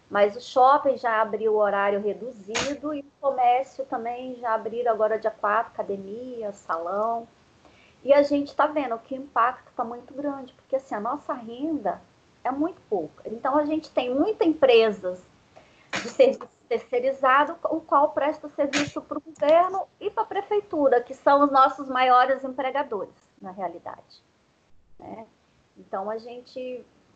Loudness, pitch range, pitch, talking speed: -24 LUFS, 230-295 Hz, 265 Hz, 155 wpm